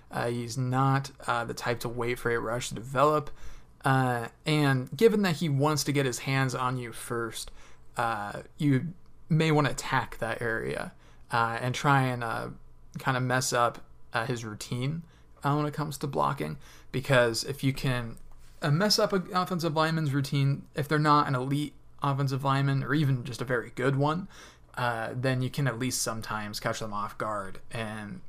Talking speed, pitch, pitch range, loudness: 190 wpm, 130 Hz, 120-145 Hz, -29 LUFS